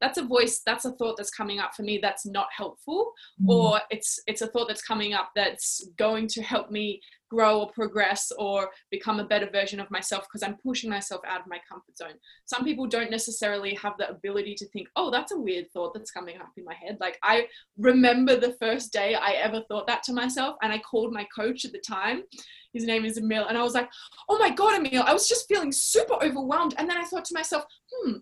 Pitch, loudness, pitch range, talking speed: 220 Hz, -26 LUFS, 205-255 Hz, 235 wpm